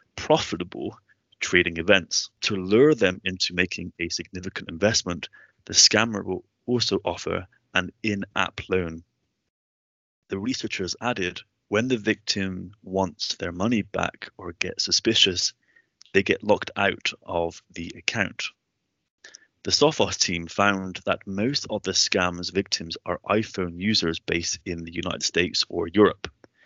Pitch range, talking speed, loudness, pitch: 85-100 Hz, 135 wpm, -24 LUFS, 95 Hz